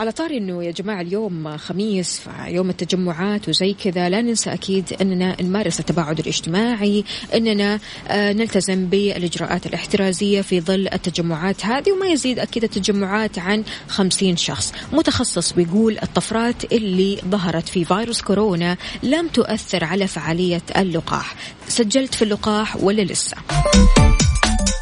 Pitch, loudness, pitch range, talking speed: 195 Hz, -19 LUFS, 175-215 Hz, 125 wpm